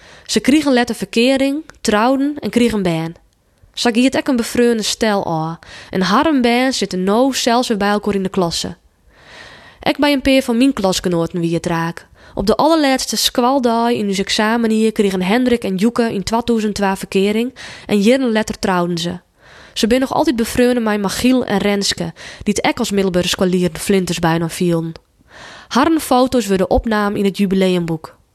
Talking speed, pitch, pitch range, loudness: 175 wpm, 215 Hz, 190-245 Hz, -16 LUFS